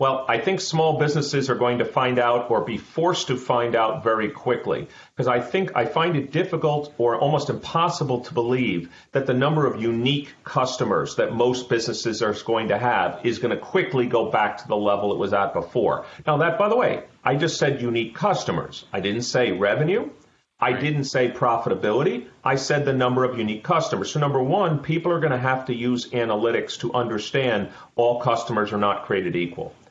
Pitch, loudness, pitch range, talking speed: 125 Hz, -23 LUFS, 120-150 Hz, 200 wpm